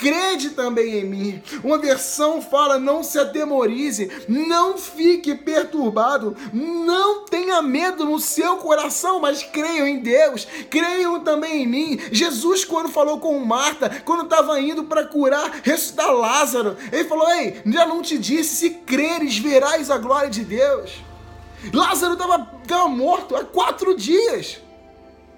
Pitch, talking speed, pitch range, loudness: 300 Hz, 140 wpm, 270-335 Hz, -19 LUFS